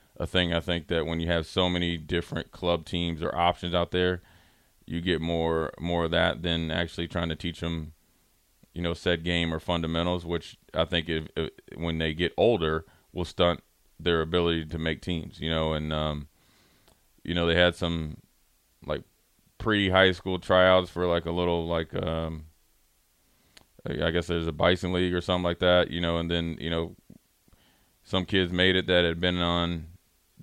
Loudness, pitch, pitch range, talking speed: -27 LUFS, 85 Hz, 80-90 Hz, 185 wpm